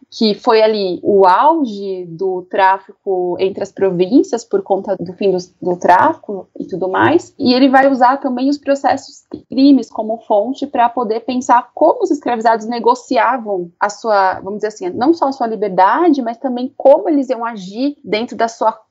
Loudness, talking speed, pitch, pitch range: -15 LUFS, 180 wpm, 230 Hz, 195-270 Hz